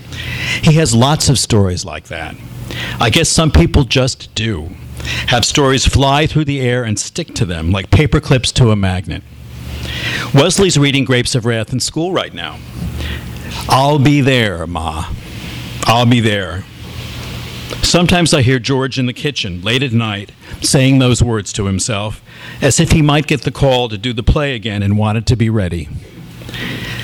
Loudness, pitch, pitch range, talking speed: -14 LUFS, 120 Hz, 95-135 Hz, 170 wpm